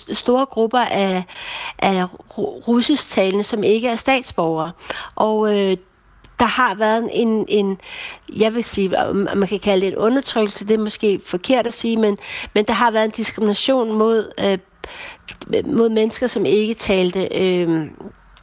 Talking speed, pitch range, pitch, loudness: 155 wpm, 195-240 Hz, 220 Hz, -19 LUFS